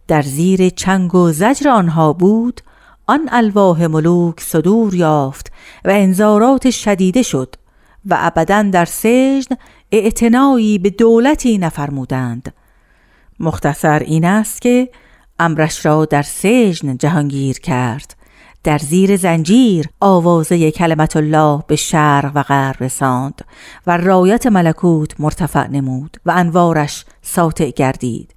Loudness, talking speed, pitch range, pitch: -13 LUFS, 115 wpm, 150-210 Hz, 170 Hz